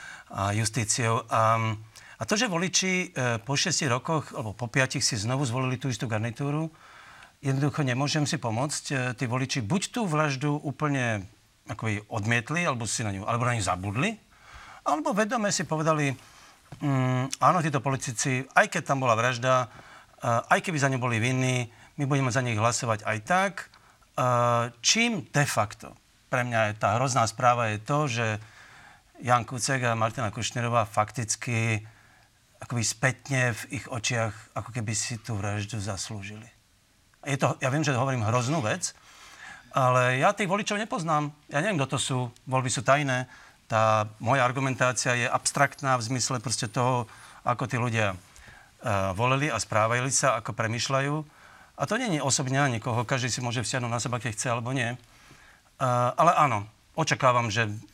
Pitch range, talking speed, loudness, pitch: 115-140 Hz, 165 wpm, -27 LUFS, 125 Hz